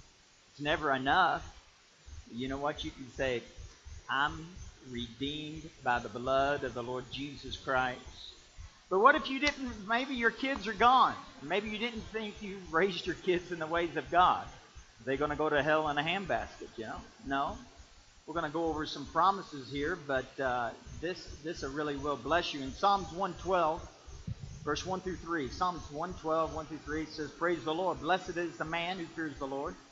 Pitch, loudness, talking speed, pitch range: 155 Hz, -33 LUFS, 190 wpm, 140-180 Hz